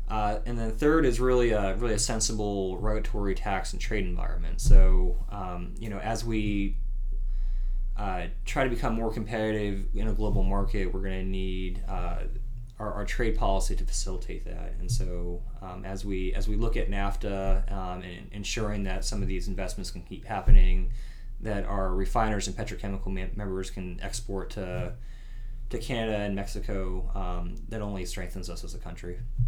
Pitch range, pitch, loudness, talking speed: 95-110 Hz, 100 Hz, -31 LUFS, 175 wpm